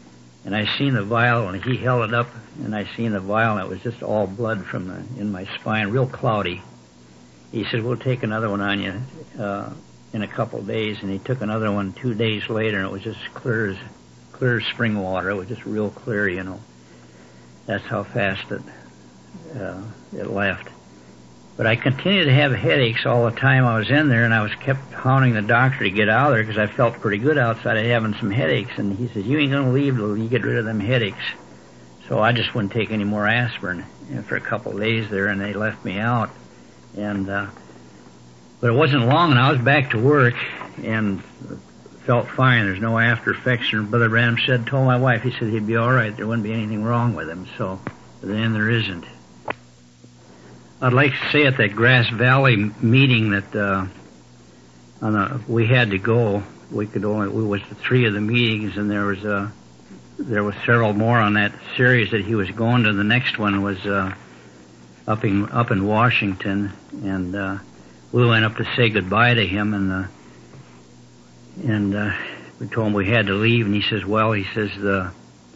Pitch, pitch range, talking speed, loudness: 110 Hz, 95-120 Hz, 210 wpm, -20 LUFS